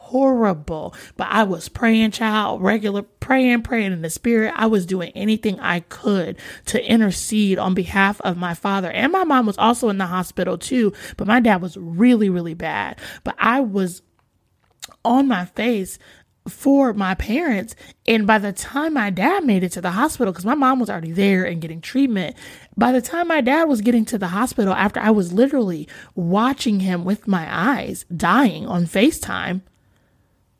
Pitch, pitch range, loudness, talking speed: 210 Hz, 185-240 Hz, -19 LUFS, 180 wpm